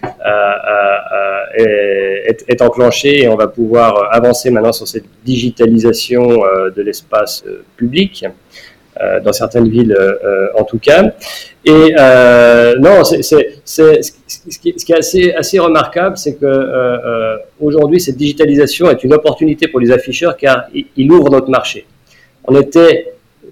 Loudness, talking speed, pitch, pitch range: -10 LUFS, 160 wpm, 130 Hz, 115-170 Hz